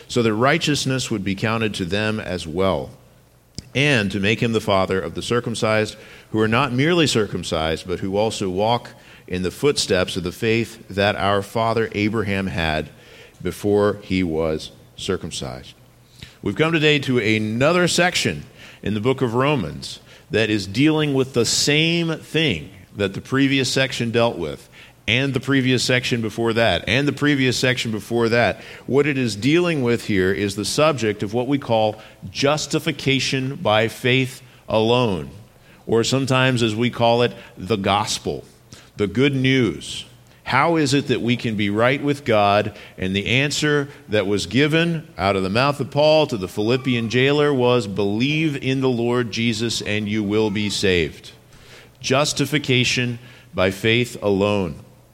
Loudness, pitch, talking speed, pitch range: -20 LUFS, 120 Hz, 160 wpm, 105-135 Hz